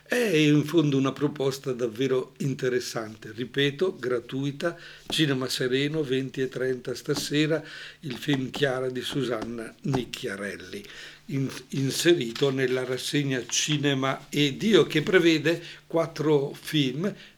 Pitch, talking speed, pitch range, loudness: 140 Hz, 100 wpm, 130-155 Hz, -26 LUFS